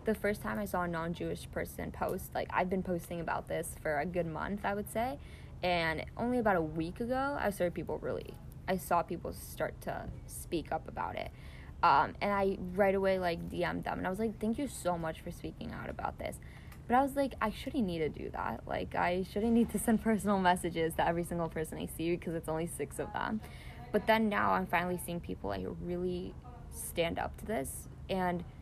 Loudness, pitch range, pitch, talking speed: -35 LUFS, 170-210 Hz, 180 Hz, 225 wpm